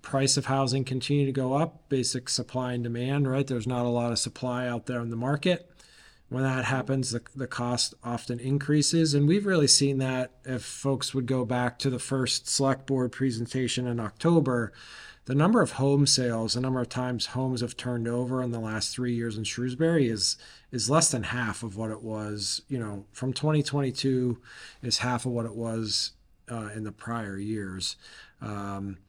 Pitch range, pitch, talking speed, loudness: 115-135 Hz, 125 Hz, 195 wpm, -28 LUFS